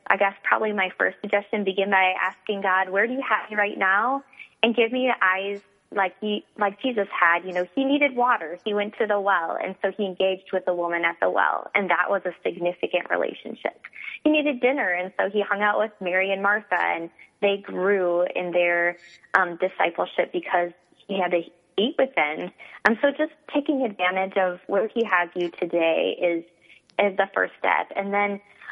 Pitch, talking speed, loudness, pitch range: 195 Hz, 205 wpm, -24 LUFS, 180-215 Hz